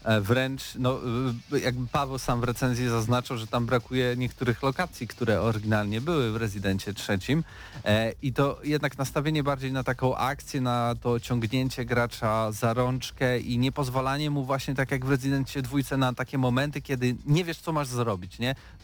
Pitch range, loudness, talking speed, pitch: 120-135 Hz, -28 LUFS, 170 wpm, 125 Hz